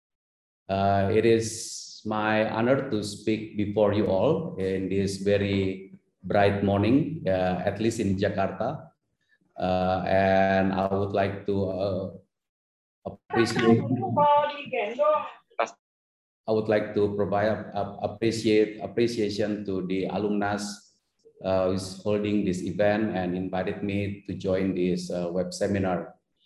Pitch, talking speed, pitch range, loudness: 100 Hz, 120 wpm, 95-105 Hz, -26 LUFS